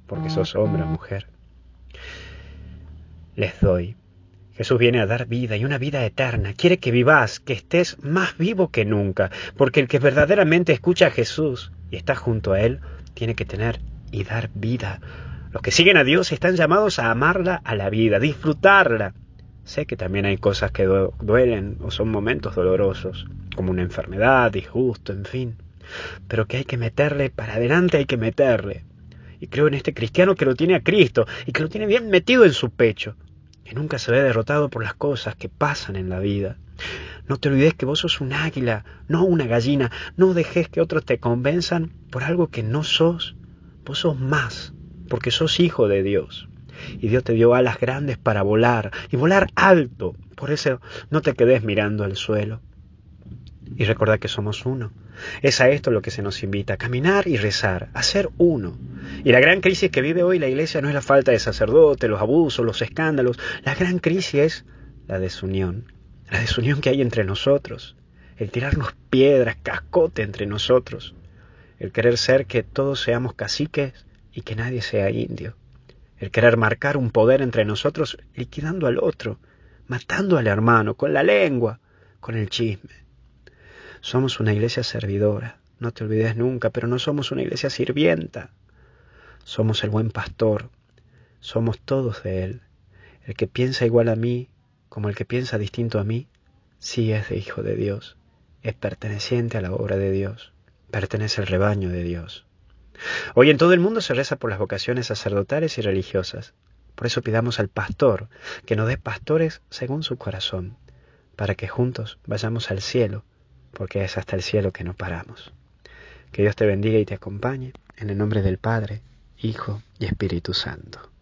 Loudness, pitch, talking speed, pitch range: -21 LUFS, 115 Hz, 180 wpm, 100-135 Hz